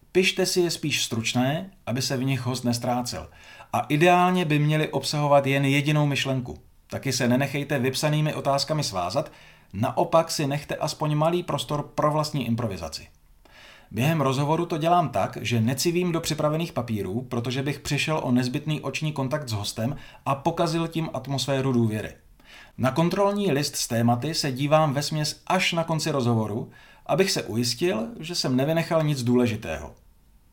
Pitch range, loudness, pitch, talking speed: 120-155 Hz, -25 LUFS, 140 Hz, 155 wpm